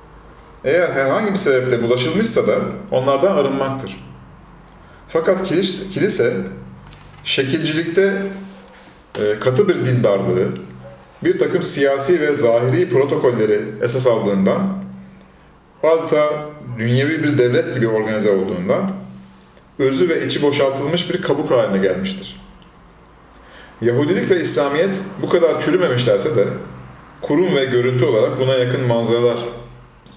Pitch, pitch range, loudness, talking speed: 125 Hz, 100-150 Hz, -17 LUFS, 105 wpm